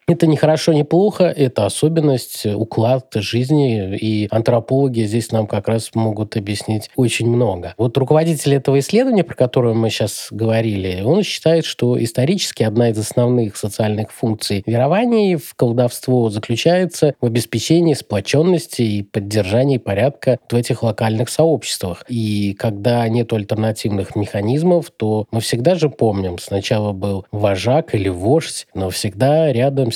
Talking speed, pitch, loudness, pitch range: 140 wpm, 120 Hz, -17 LUFS, 110-140 Hz